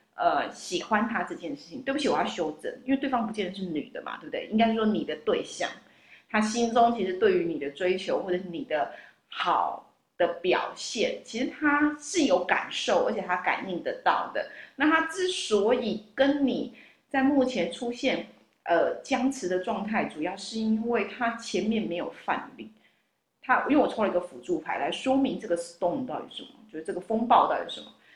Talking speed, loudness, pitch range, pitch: 295 characters per minute, -28 LUFS, 205-270 Hz, 235 Hz